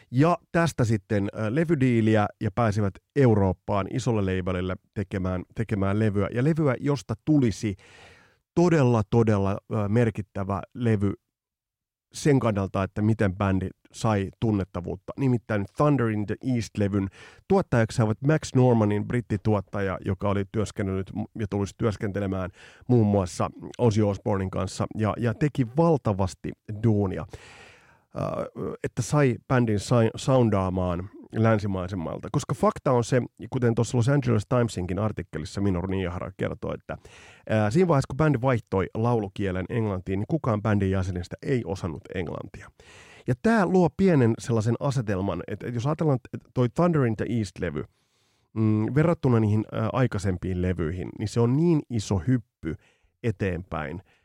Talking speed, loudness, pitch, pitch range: 120 wpm, -26 LUFS, 110 Hz, 100-125 Hz